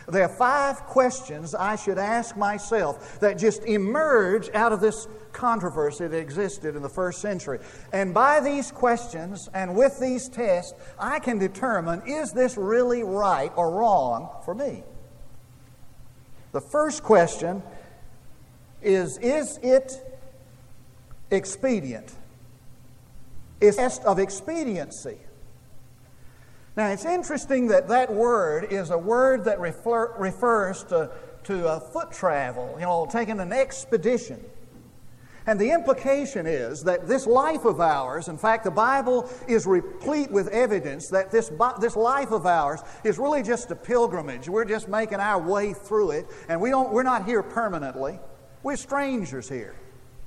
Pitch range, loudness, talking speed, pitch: 175-250 Hz, -24 LUFS, 140 wpm, 215 Hz